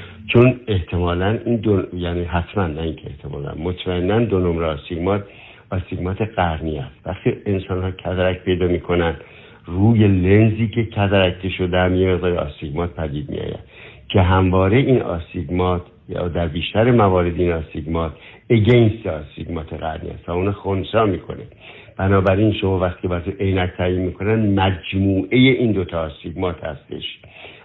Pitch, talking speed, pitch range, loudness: 95 Hz, 145 wpm, 85-100 Hz, -19 LUFS